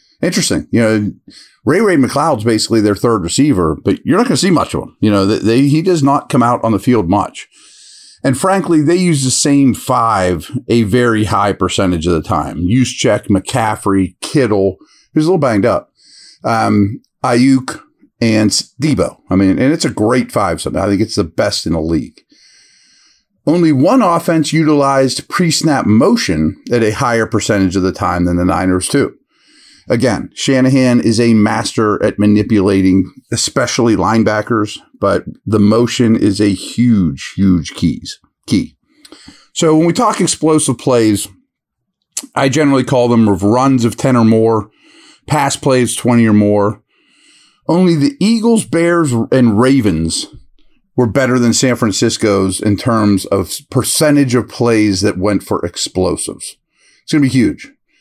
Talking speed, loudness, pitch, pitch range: 160 wpm, -13 LUFS, 115 Hz, 105-135 Hz